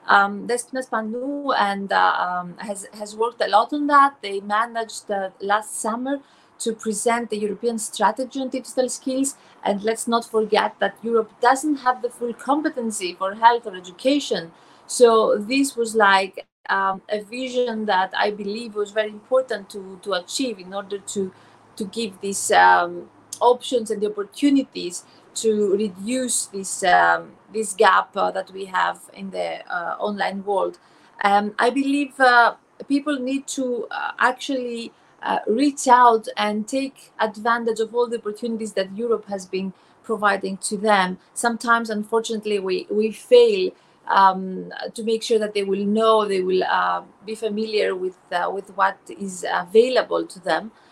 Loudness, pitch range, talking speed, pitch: -21 LUFS, 200-245 Hz, 160 wpm, 220 Hz